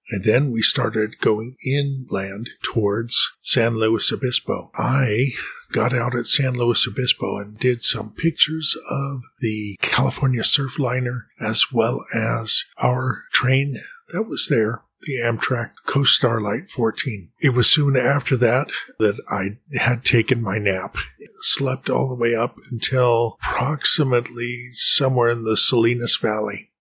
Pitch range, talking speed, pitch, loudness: 115-130 Hz, 140 wpm, 120 Hz, -19 LUFS